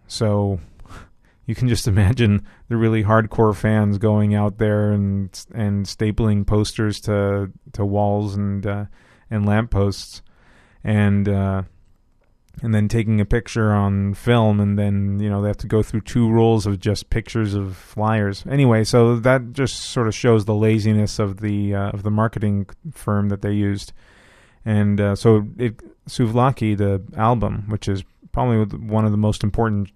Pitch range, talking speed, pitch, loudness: 100-110 Hz, 165 wpm, 105 Hz, -20 LUFS